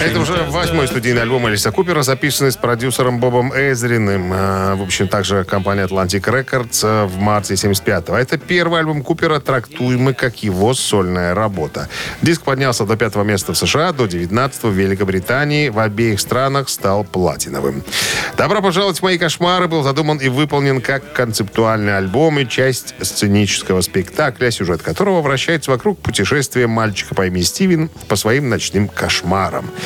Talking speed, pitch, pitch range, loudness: 150 wpm, 125 Hz, 100-140 Hz, -16 LUFS